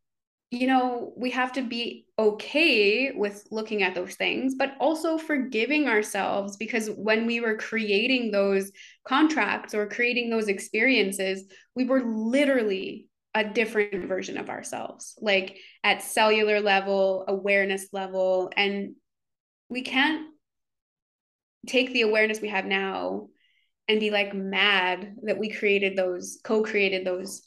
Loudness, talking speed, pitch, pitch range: -25 LUFS, 135 wpm, 215 Hz, 195-250 Hz